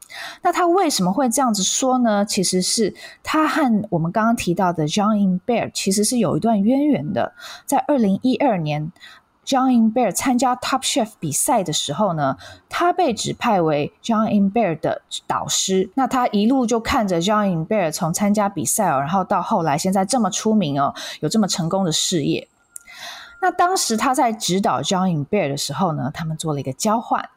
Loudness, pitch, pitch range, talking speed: -19 LUFS, 210 Hz, 180-255 Hz, 355 characters per minute